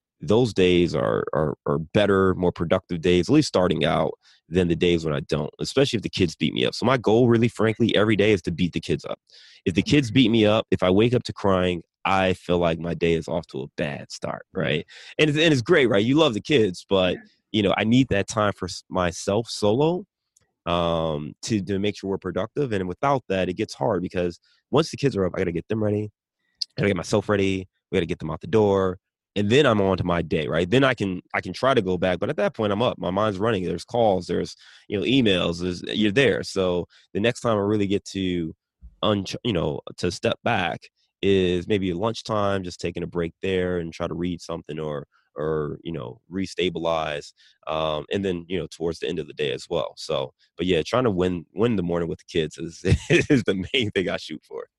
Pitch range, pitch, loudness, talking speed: 85-105 Hz, 95 Hz, -23 LUFS, 245 wpm